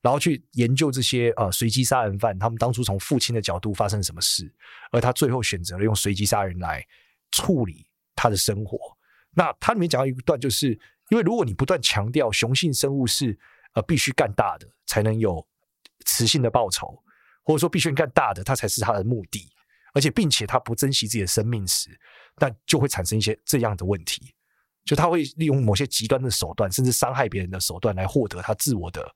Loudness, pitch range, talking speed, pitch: -23 LUFS, 105-140 Hz, 315 characters per minute, 120 Hz